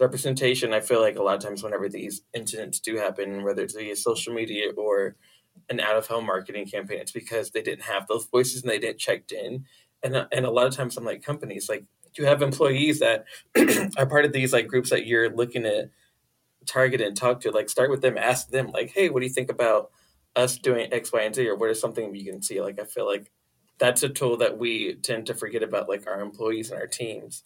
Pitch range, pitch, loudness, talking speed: 120-180 Hz, 130 Hz, -25 LUFS, 240 wpm